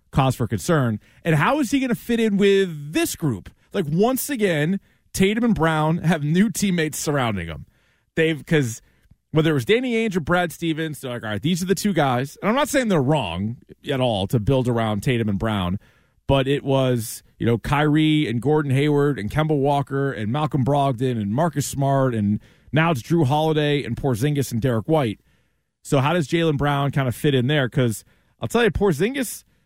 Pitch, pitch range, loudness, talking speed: 145 Hz, 125-170 Hz, -21 LUFS, 205 wpm